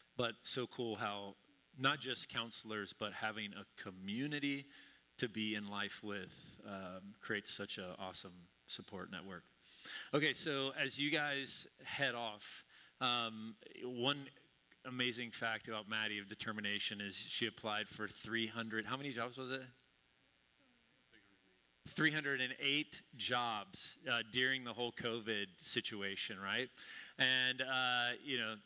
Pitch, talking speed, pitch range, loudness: 115 Hz, 130 wpm, 105-130 Hz, -40 LUFS